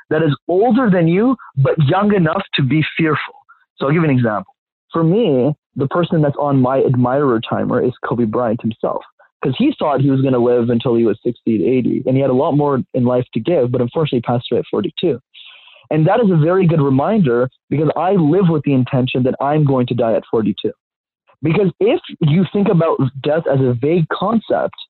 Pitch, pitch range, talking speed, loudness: 145 Hz, 125-170 Hz, 220 wpm, -16 LUFS